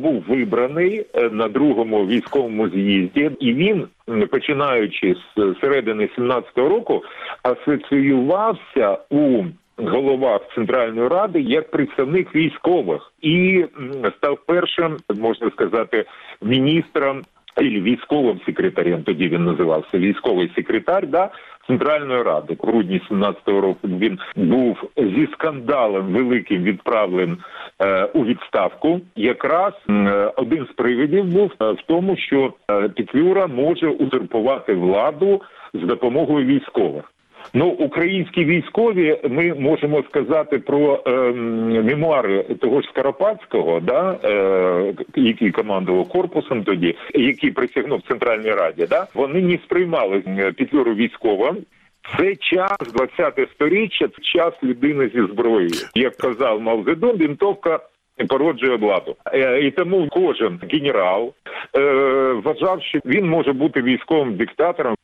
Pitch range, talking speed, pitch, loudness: 125-200 Hz, 115 wpm, 155 Hz, -19 LUFS